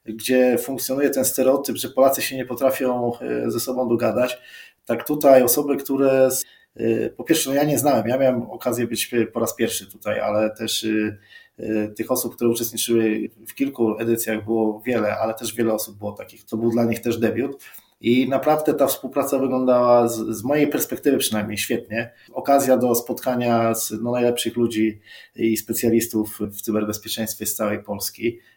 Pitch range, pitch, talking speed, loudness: 110-130 Hz, 115 Hz, 170 wpm, -21 LUFS